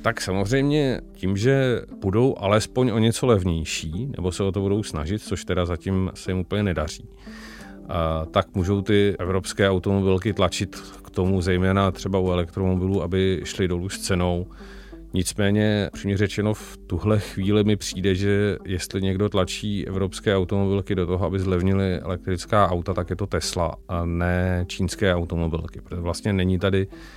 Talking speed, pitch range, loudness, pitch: 155 wpm, 90-100 Hz, -23 LUFS, 95 Hz